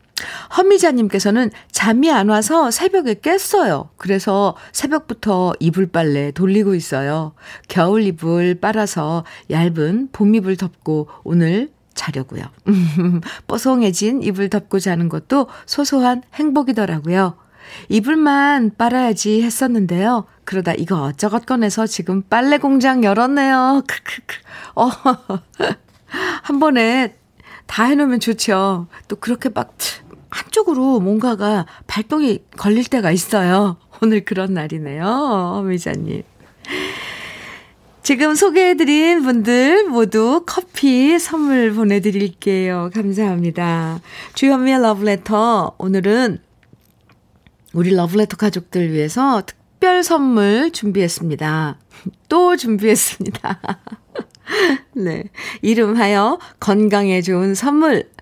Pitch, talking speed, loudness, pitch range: 215 Hz, 240 characters per minute, -16 LUFS, 185-260 Hz